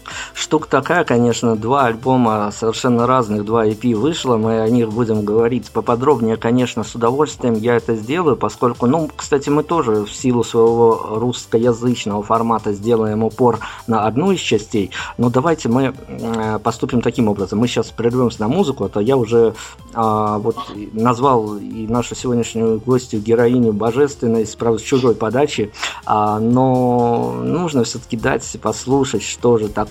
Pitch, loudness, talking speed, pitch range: 115 Hz, -17 LUFS, 145 wpm, 110-125 Hz